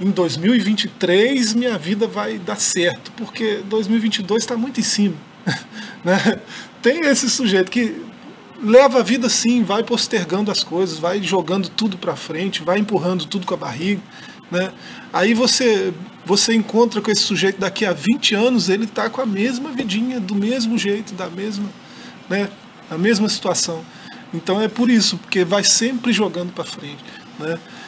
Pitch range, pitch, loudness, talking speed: 190-230 Hz, 210 Hz, -18 LUFS, 160 wpm